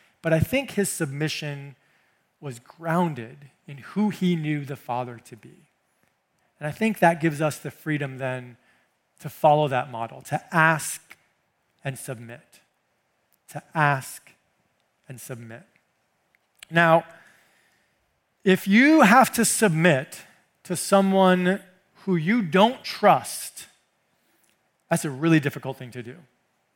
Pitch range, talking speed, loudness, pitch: 135-185 Hz, 125 wpm, -22 LUFS, 155 Hz